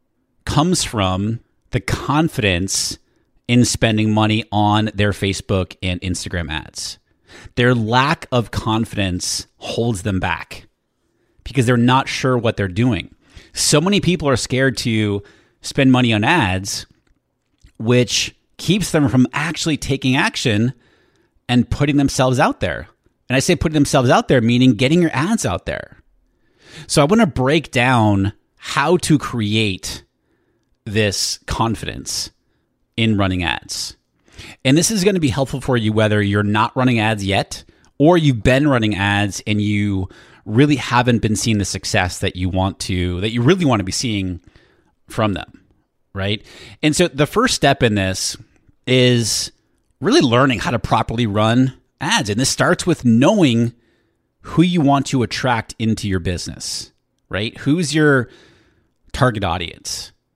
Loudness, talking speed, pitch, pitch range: -17 LUFS, 150 wpm, 115 Hz, 100-135 Hz